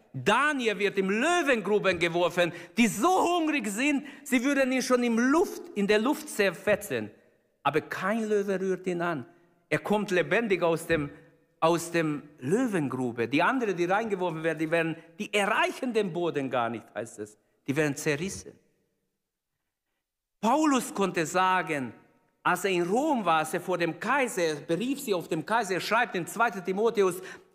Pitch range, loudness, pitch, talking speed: 165-235 Hz, -27 LUFS, 190 Hz, 165 wpm